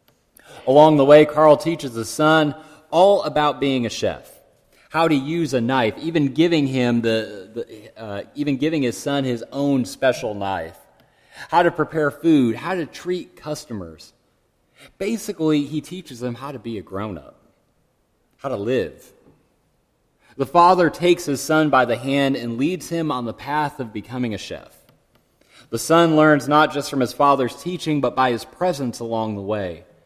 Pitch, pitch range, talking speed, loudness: 145 Hz, 120-155 Hz, 170 wpm, -19 LUFS